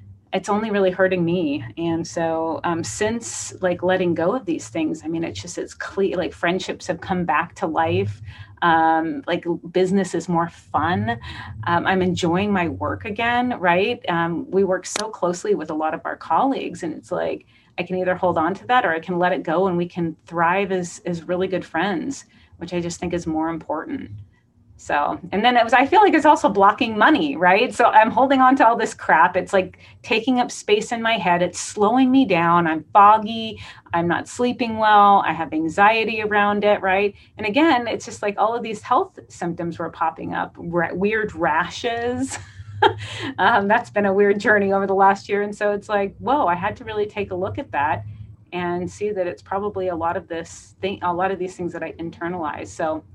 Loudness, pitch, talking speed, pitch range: -20 LUFS, 185 Hz, 210 wpm, 170-210 Hz